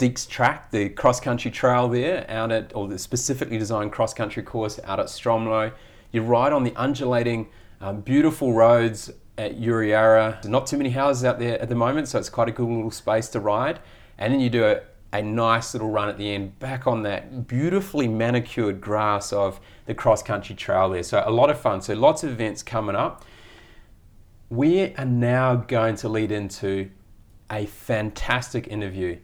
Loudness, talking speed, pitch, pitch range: -23 LUFS, 185 wpm, 115 Hz, 105-125 Hz